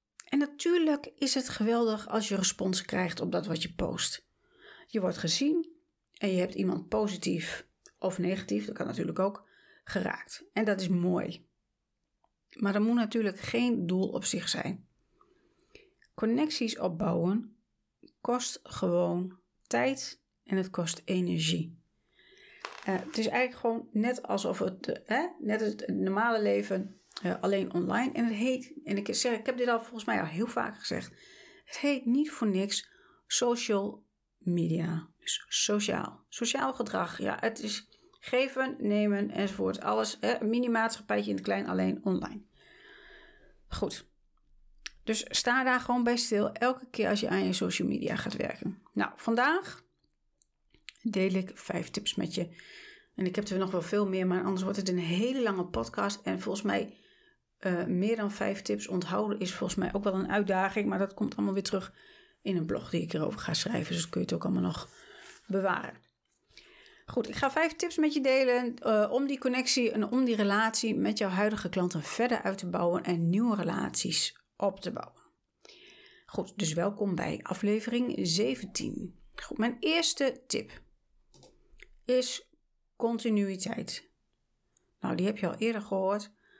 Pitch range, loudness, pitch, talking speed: 190-255 Hz, -31 LUFS, 215 Hz, 165 wpm